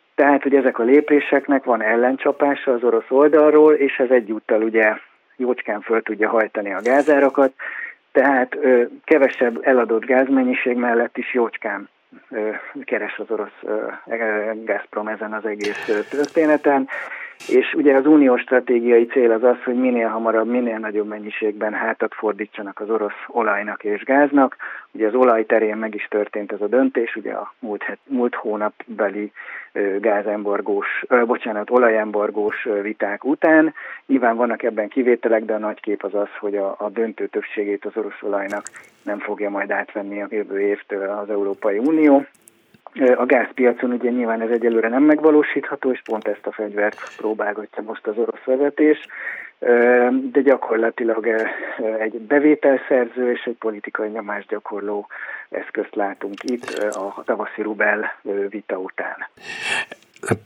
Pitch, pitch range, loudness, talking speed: 115 Hz, 105-130 Hz, -19 LUFS, 140 wpm